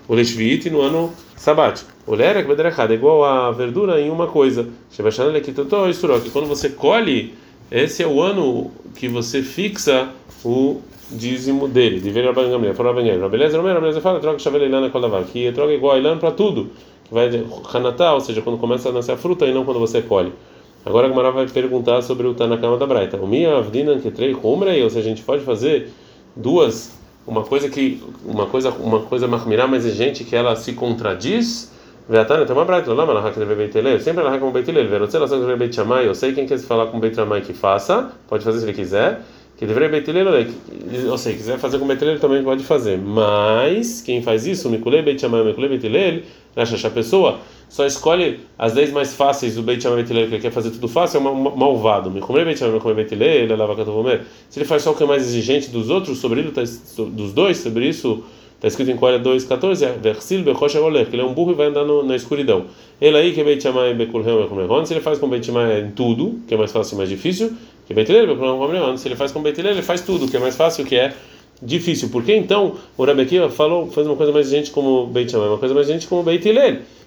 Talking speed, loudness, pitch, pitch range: 245 wpm, -18 LUFS, 130 Hz, 115-155 Hz